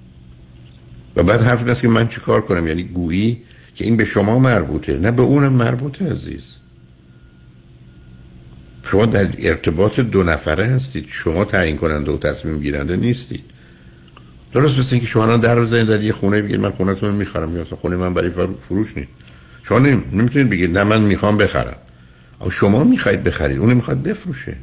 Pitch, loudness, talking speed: 95 Hz, -17 LUFS, 170 wpm